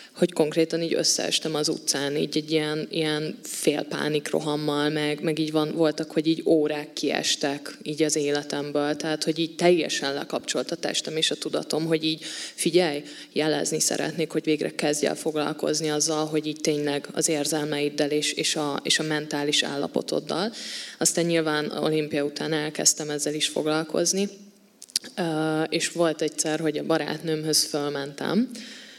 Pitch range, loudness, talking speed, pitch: 150-160 Hz, -25 LUFS, 150 wpm, 155 Hz